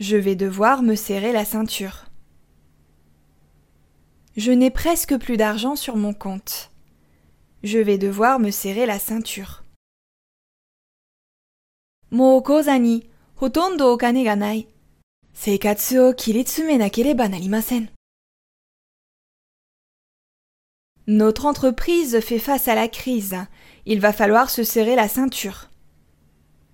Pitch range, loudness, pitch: 180-245 Hz, -19 LUFS, 215 Hz